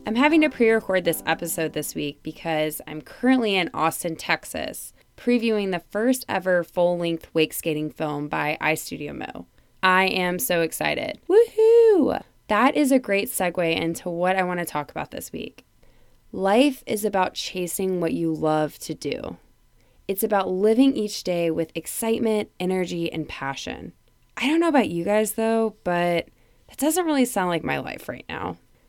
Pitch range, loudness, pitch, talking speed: 165-225 Hz, -23 LUFS, 185 Hz, 165 wpm